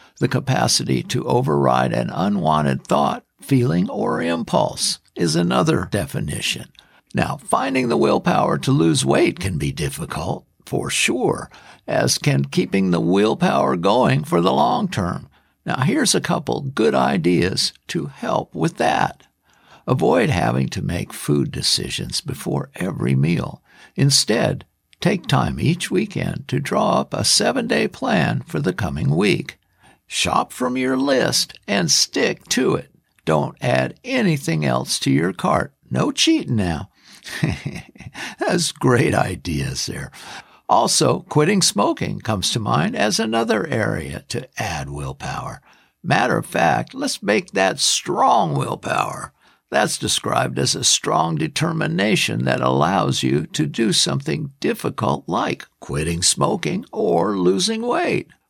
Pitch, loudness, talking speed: 90 Hz, -19 LUFS, 135 wpm